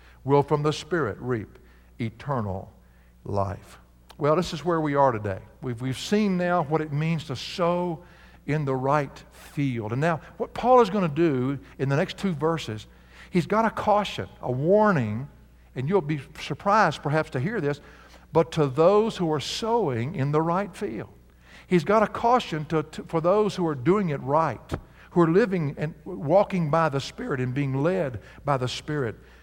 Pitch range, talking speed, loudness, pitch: 130-180 Hz, 185 wpm, -25 LUFS, 155 Hz